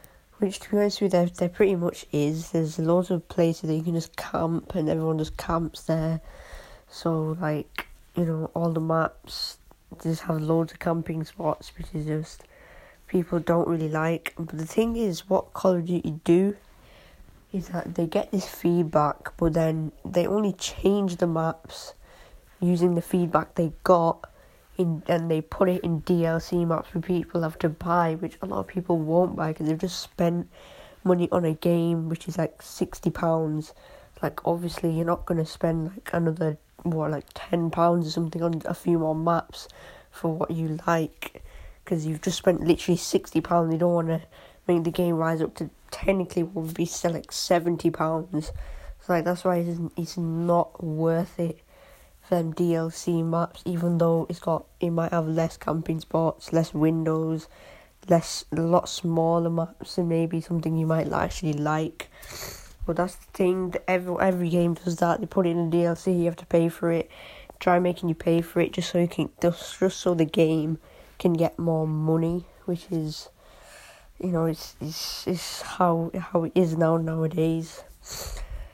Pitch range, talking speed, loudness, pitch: 160-175 Hz, 185 wpm, -26 LUFS, 170 Hz